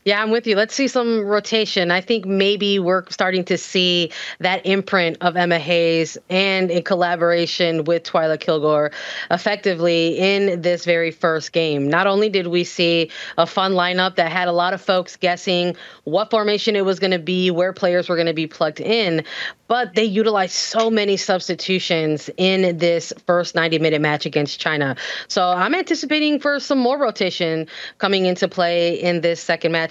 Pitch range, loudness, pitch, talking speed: 170-200 Hz, -19 LUFS, 180 Hz, 180 wpm